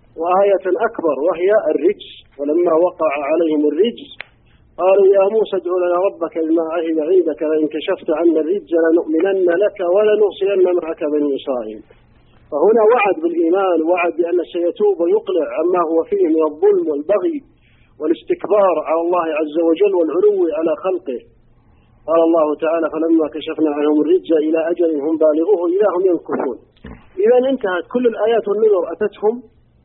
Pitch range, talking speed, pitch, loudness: 160-210 Hz, 135 wpm, 175 Hz, -16 LUFS